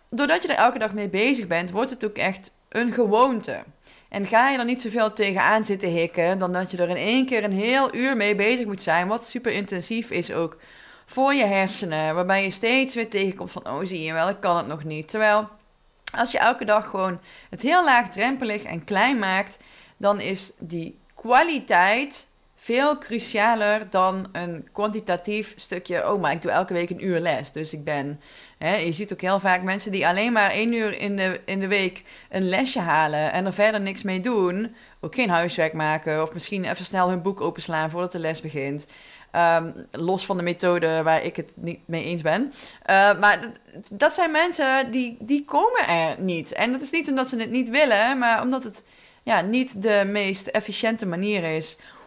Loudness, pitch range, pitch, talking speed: -23 LUFS, 175-230 Hz, 200 Hz, 205 wpm